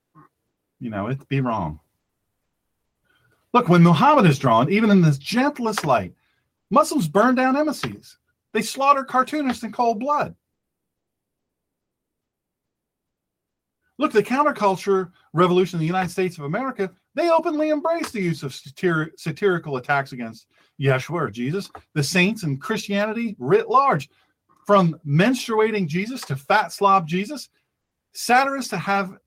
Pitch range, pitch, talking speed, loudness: 160-255 Hz, 195 Hz, 130 wpm, -21 LUFS